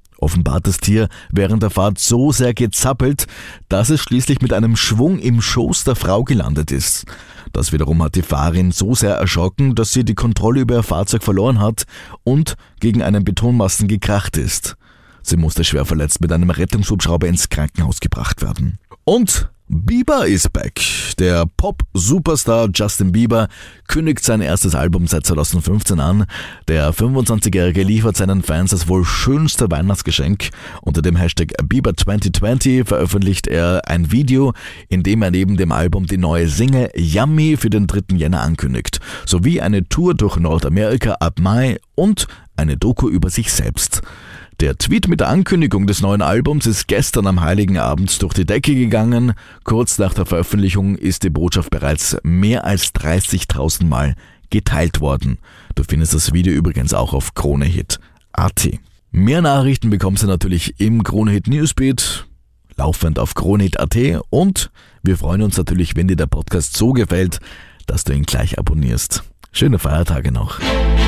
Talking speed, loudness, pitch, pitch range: 155 wpm, -16 LUFS, 95 Hz, 85-115 Hz